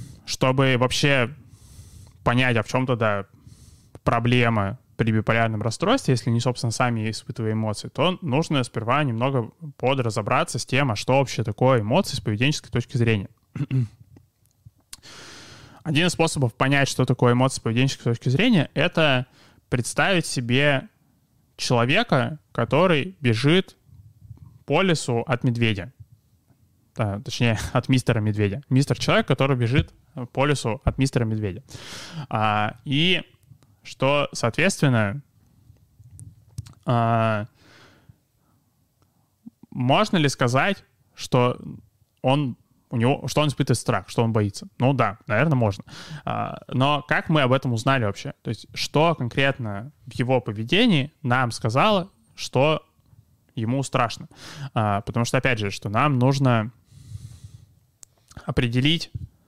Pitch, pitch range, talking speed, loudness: 125 Hz, 115-140 Hz, 120 wpm, -22 LUFS